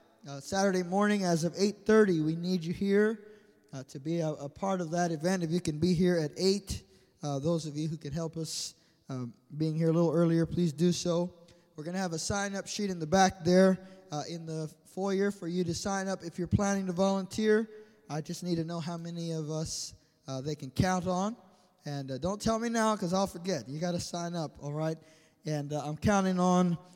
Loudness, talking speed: -31 LUFS, 230 wpm